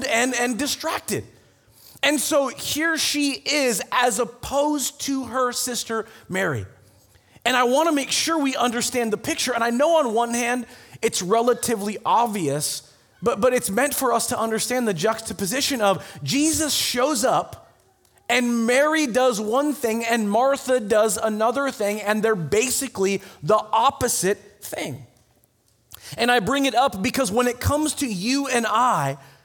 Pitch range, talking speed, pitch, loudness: 210-265 Hz, 155 wpm, 240 Hz, -22 LUFS